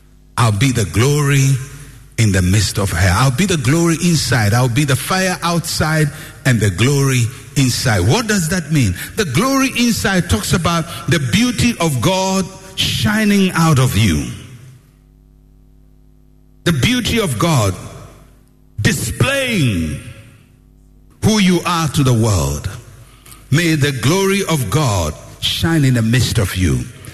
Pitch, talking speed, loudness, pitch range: 130 Hz, 135 wpm, -15 LUFS, 110-160 Hz